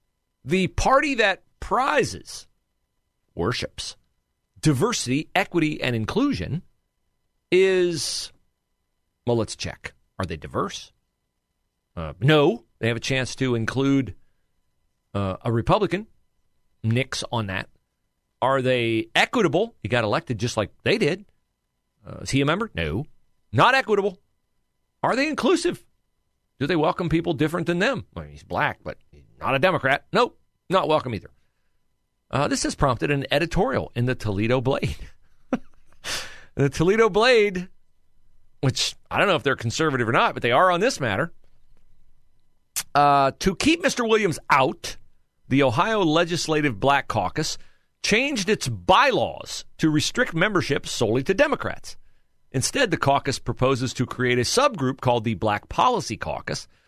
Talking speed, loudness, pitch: 140 wpm, -23 LUFS, 130 Hz